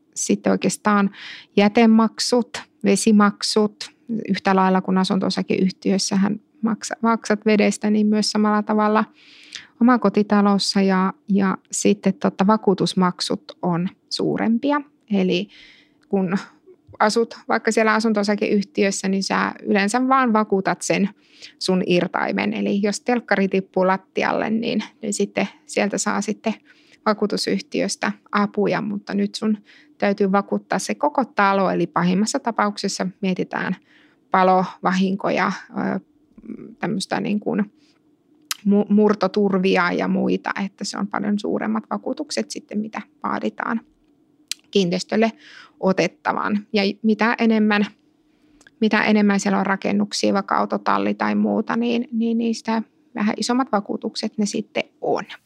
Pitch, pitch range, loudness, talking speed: 210 Hz, 200-235 Hz, -21 LUFS, 110 wpm